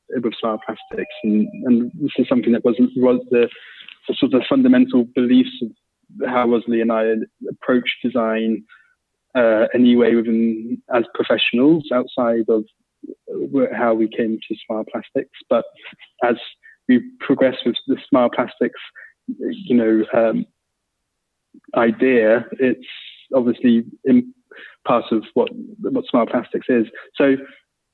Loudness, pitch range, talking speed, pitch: -19 LUFS, 115-150 Hz, 130 wpm, 125 Hz